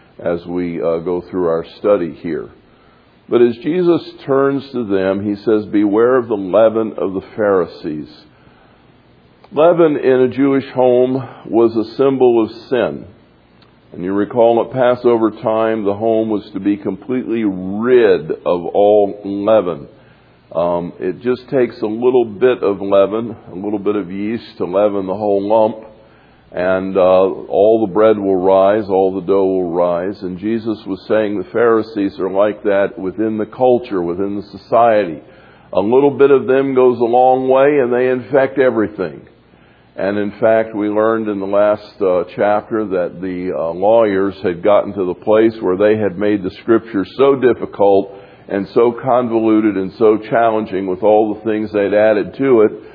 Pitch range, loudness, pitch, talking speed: 100-120 Hz, -15 LUFS, 110 Hz, 170 wpm